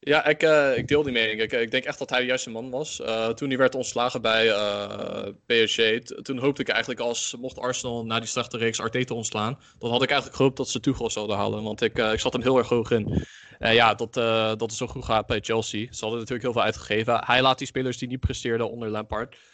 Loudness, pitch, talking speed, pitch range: -25 LUFS, 120 Hz, 265 wpm, 110-130 Hz